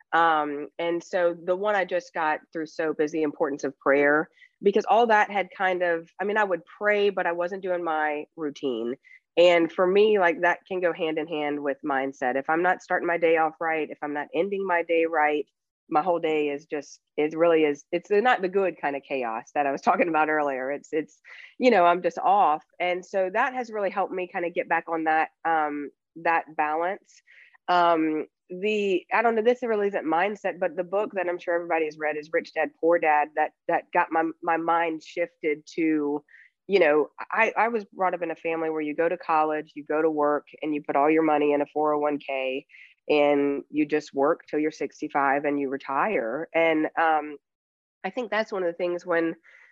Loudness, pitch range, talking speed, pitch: -25 LUFS, 150-180 Hz, 225 wpm, 165 Hz